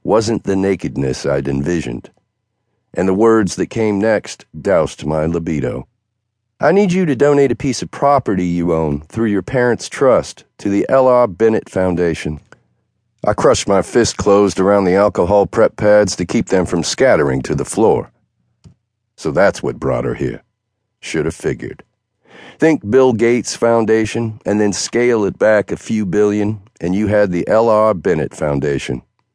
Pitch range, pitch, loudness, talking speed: 85-115 Hz, 105 Hz, -15 LUFS, 165 wpm